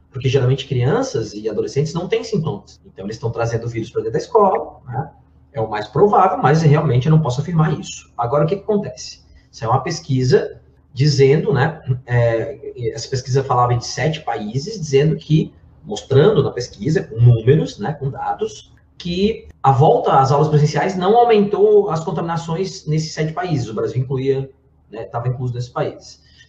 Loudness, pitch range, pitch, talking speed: -18 LUFS, 125-165 Hz, 140 Hz, 175 wpm